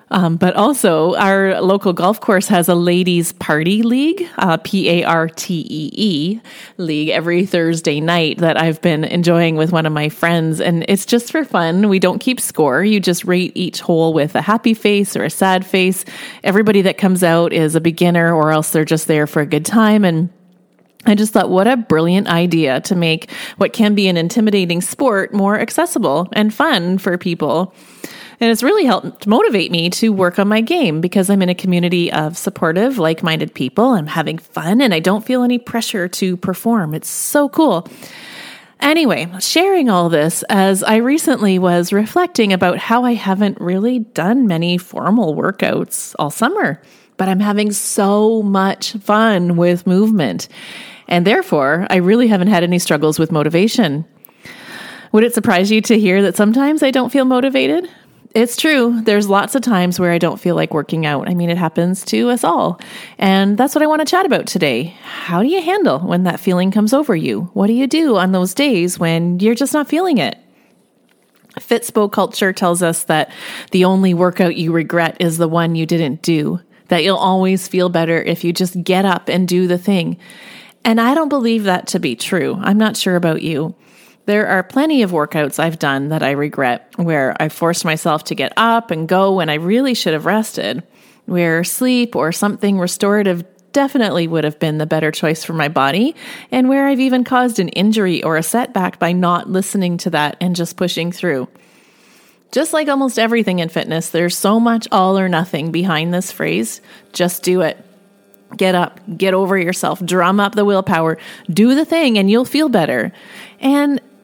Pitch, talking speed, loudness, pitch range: 190 Hz, 190 wpm, -15 LUFS, 170-225 Hz